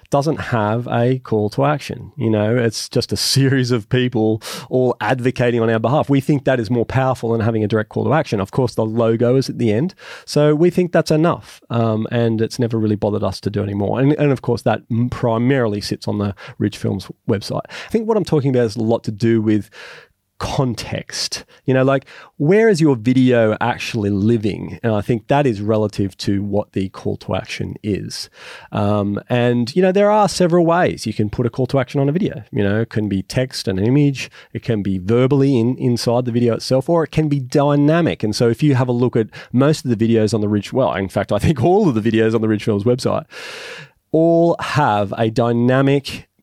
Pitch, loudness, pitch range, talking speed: 120 Hz, -18 LUFS, 110-140 Hz, 225 wpm